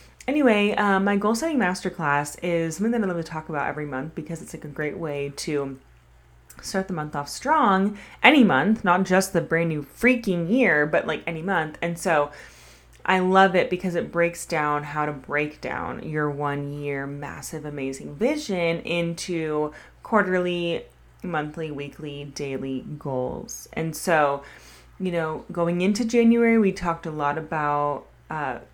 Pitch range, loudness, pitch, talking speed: 145-185 Hz, -24 LUFS, 160 Hz, 165 wpm